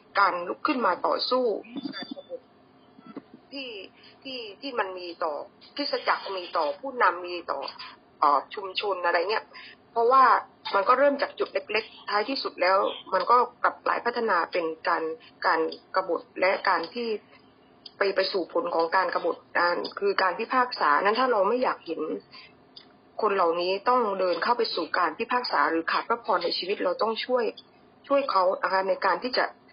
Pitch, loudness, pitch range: 215 Hz, -26 LUFS, 185-255 Hz